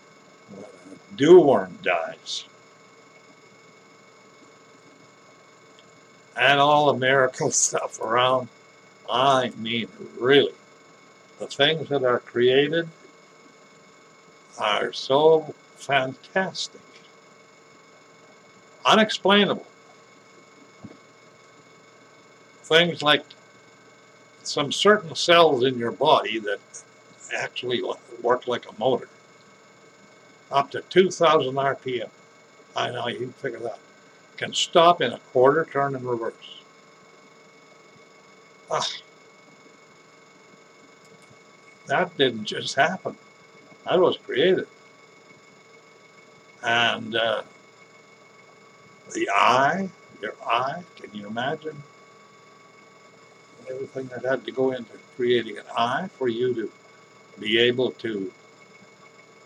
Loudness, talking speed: -22 LUFS, 85 wpm